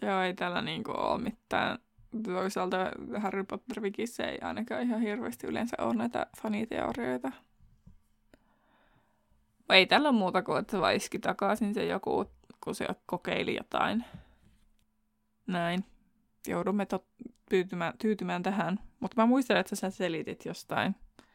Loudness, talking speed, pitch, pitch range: -31 LUFS, 135 wpm, 195 Hz, 180-220 Hz